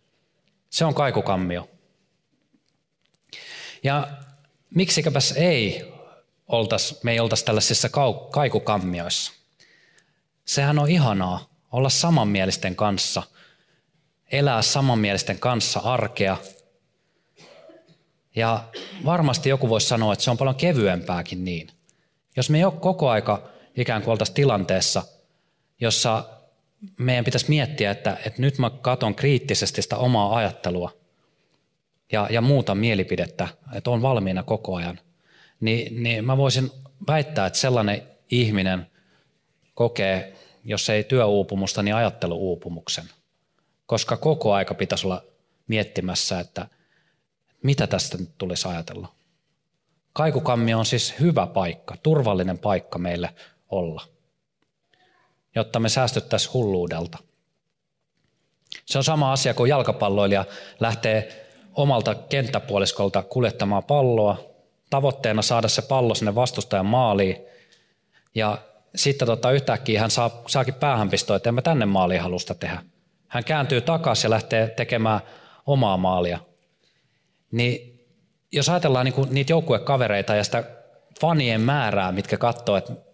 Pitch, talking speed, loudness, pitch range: 115 Hz, 115 wpm, -23 LUFS, 100-140 Hz